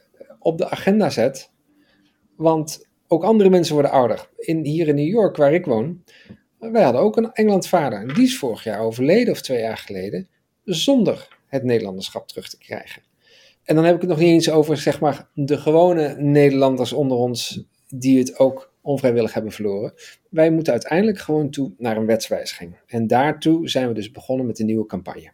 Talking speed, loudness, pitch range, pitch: 185 wpm, -19 LUFS, 125-170 Hz, 150 Hz